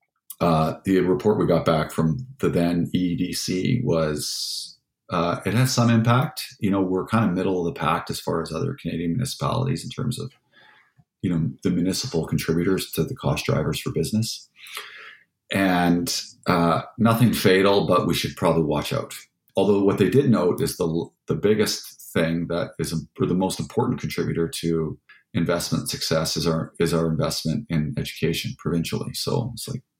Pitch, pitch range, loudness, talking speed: 90 Hz, 85-110 Hz, -23 LUFS, 175 wpm